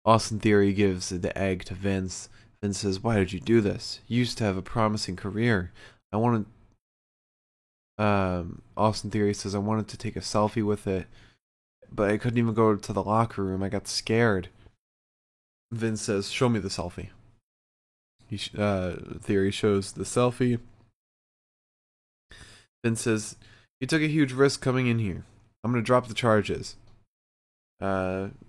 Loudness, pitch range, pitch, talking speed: -27 LUFS, 95-115 Hz, 105 Hz, 160 wpm